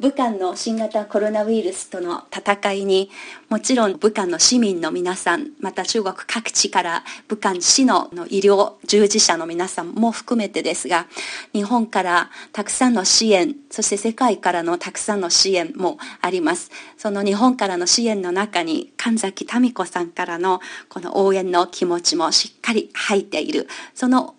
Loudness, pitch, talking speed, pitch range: -19 LUFS, 205 Hz, 320 characters per minute, 185-240 Hz